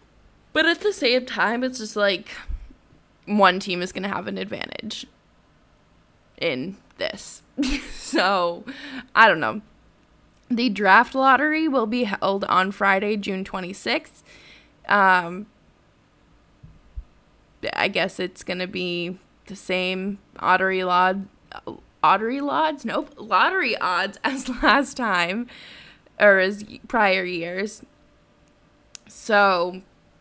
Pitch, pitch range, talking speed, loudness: 205 Hz, 185-255 Hz, 110 wpm, -22 LUFS